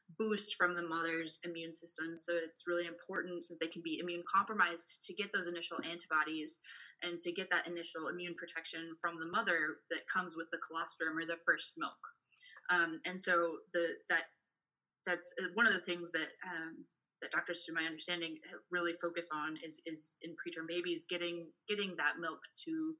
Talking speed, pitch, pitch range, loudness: 185 wpm, 170 Hz, 165-175 Hz, -38 LUFS